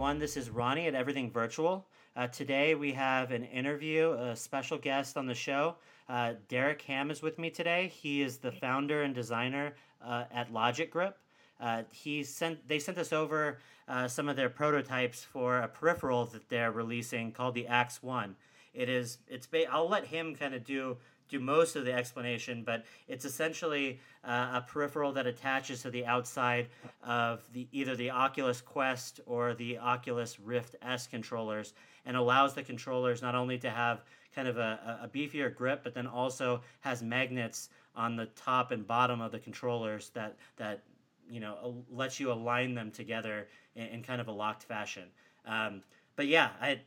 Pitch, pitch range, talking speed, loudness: 125 Hz, 120-140 Hz, 185 wpm, -34 LUFS